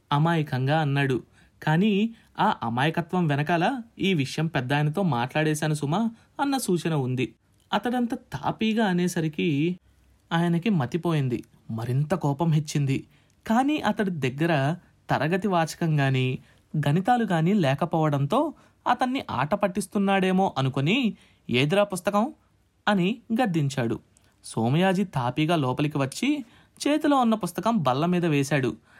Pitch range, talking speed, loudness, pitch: 140-205 Hz, 100 wpm, -25 LUFS, 170 Hz